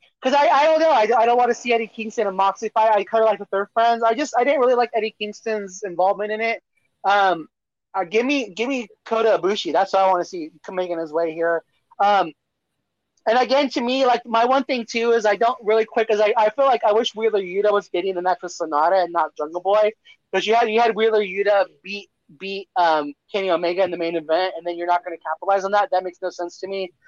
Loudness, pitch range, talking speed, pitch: -20 LUFS, 185-230 Hz, 260 wpm, 205 Hz